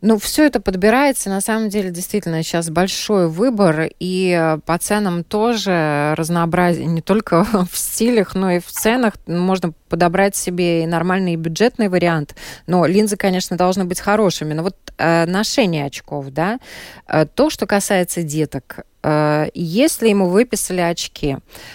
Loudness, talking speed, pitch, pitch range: -17 LUFS, 150 wpm, 180 Hz, 165-210 Hz